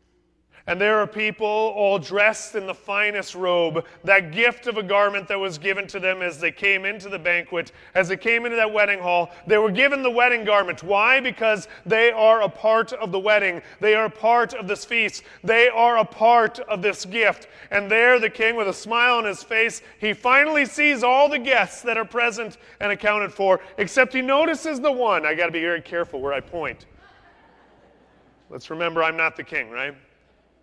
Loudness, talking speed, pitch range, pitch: -20 LUFS, 205 wpm, 190-235 Hz, 210 Hz